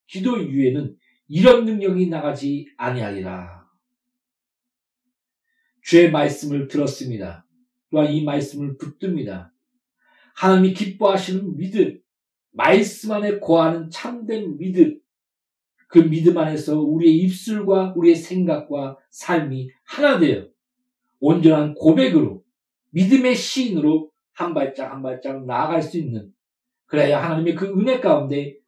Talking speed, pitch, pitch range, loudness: 260 characters per minute, 170 Hz, 145-240 Hz, -19 LUFS